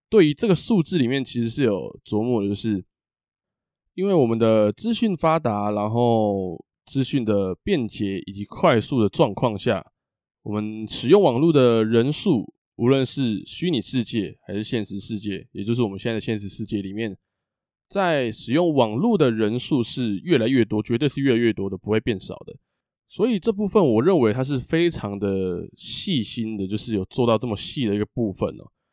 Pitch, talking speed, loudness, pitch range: 115 Hz, 275 characters per minute, -22 LUFS, 105-135 Hz